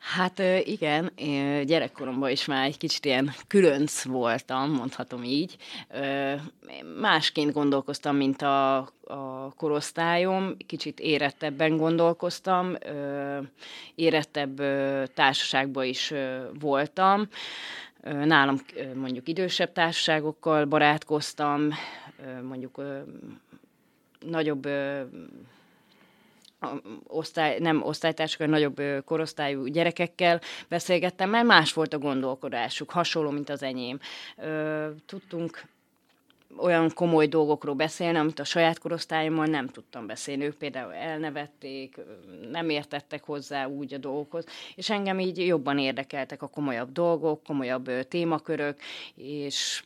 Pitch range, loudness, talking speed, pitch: 140-165 Hz, -27 LUFS, 100 wpm, 150 Hz